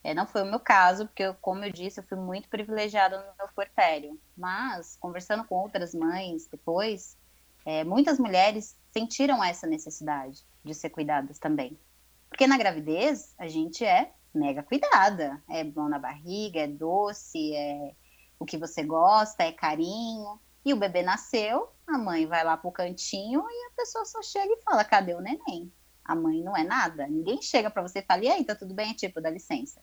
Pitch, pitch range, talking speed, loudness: 190 Hz, 160-225 Hz, 190 wpm, -28 LUFS